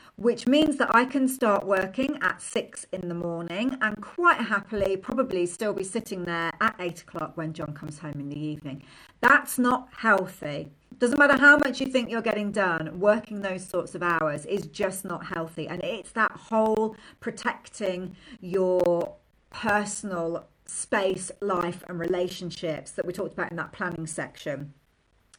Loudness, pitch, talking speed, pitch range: -26 LUFS, 190 Hz, 165 wpm, 170-220 Hz